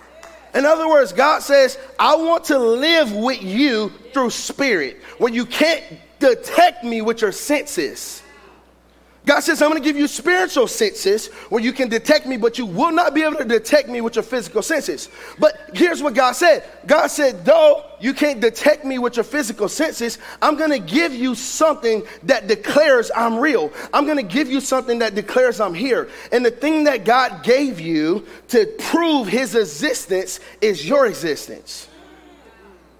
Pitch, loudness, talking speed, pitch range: 280 Hz, -18 LUFS, 175 wpm, 235-315 Hz